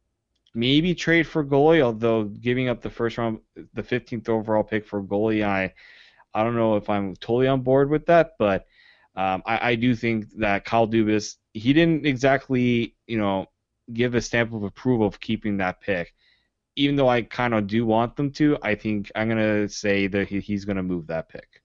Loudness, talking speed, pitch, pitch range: -23 LUFS, 200 wpm, 115 Hz, 105-125 Hz